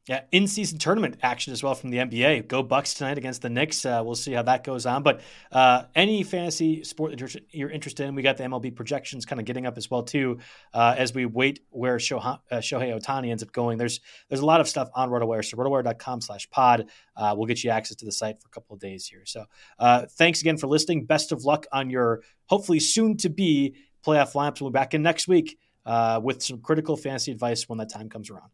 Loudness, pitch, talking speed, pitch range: -25 LUFS, 130 Hz, 240 wpm, 120-150 Hz